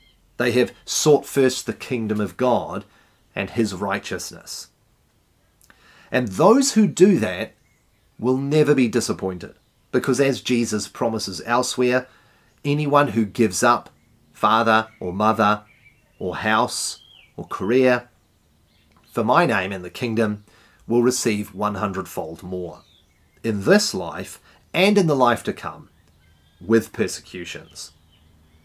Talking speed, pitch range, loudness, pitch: 120 wpm, 95-125 Hz, -21 LUFS, 110 Hz